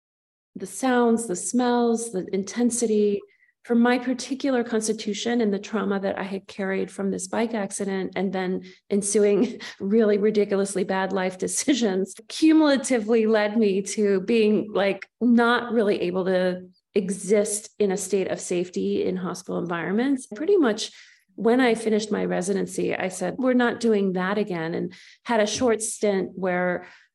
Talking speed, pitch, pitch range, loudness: 150 wpm, 210 Hz, 195-235 Hz, -24 LUFS